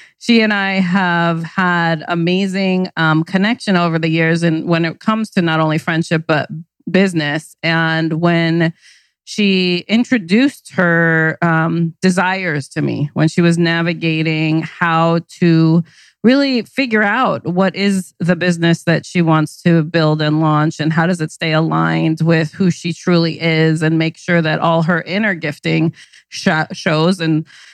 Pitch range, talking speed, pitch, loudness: 160-185 Hz, 155 wpm, 165 Hz, -15 LUFS